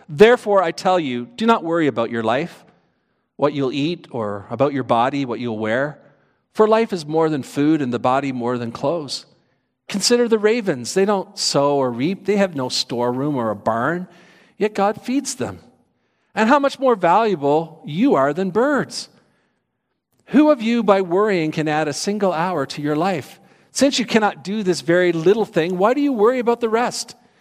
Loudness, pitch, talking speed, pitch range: -19 LUFS, 175 Hz, 195 wpm, 140-215 Hz